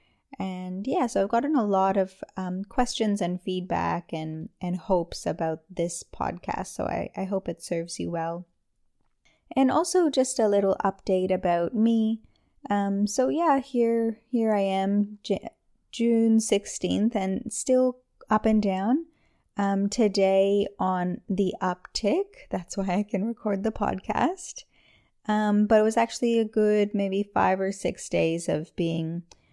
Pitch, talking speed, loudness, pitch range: 205 Hz, 150 wpm, -26 LUFS, 185-230 Hz